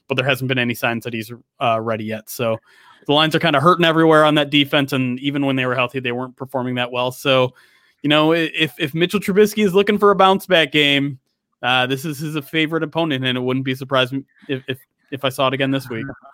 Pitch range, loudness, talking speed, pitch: 130-155 Hz, -18 LUFS, 250 wpm, 135 Hz